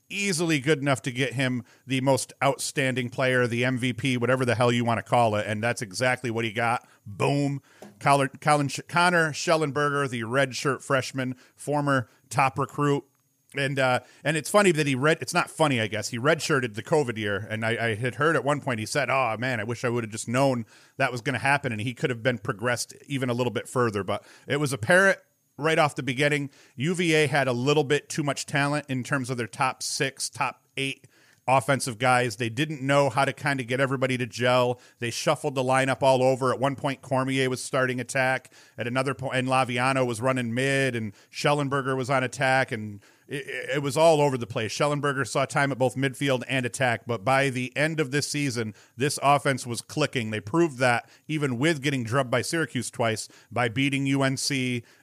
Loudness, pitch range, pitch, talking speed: -25 LUFS, 125-145 Hz, 130 Hz, 210 wpm